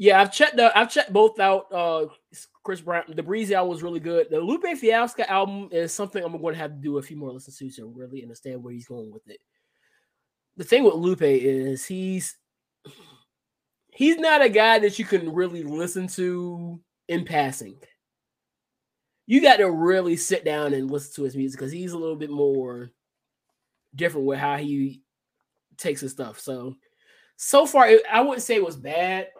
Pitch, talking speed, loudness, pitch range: 170 Hz, 195 wpm, -22 LUFS, 140-210 Hz